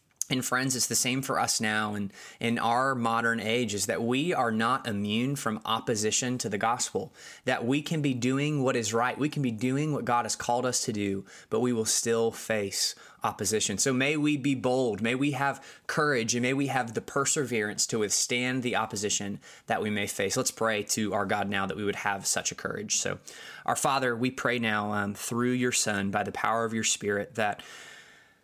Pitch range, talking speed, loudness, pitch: 105-130 Hz, 215 wpm, -28 LUFS, 120 Hz